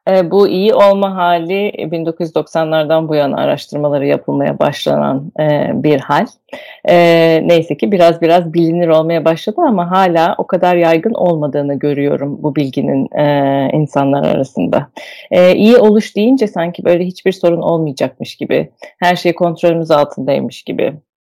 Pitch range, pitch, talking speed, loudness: 150-180 Hz, 170 Hz, 140 wpm, -13 LUFS